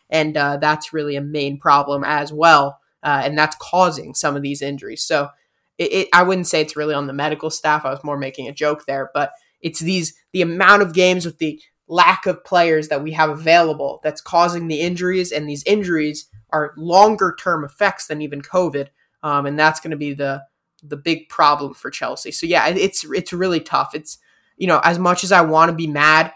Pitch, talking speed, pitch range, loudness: 155 Hz, 215 wpm, 145-175 Hz, -18 LUFS